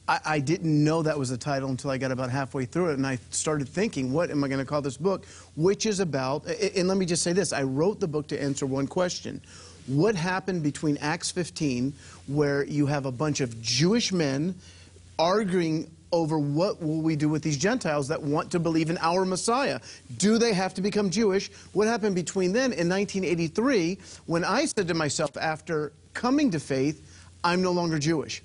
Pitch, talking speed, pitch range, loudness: 155 Hz, 205 wpm, 140-185 Hz, -26 LUFS